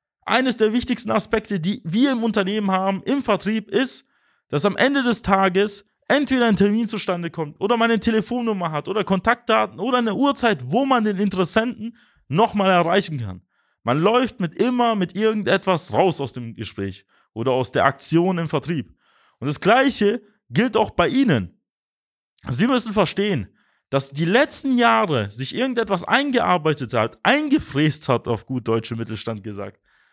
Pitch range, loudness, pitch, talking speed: 150-230 Hz, -20 LUFS, 200 Hz, 160 wpm